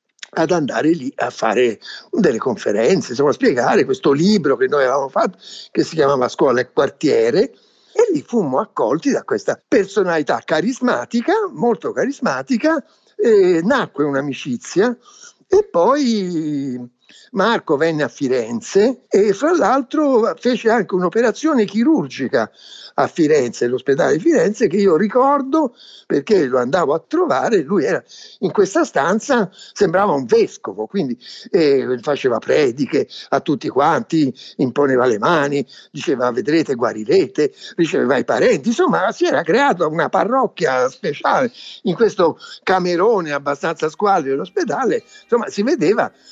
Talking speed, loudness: 130 wpm, -17 LUFS